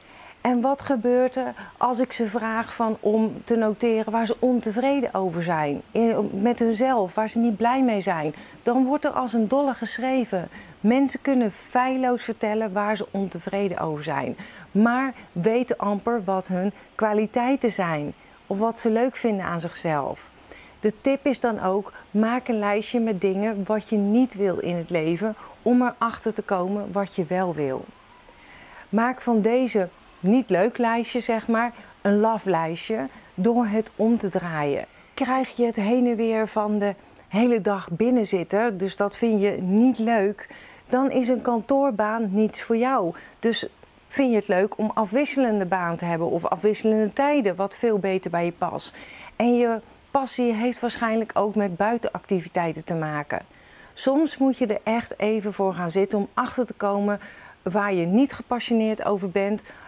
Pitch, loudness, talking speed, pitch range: 220 Hz, -24 LUFS, 170 wpm, 195-240 Hz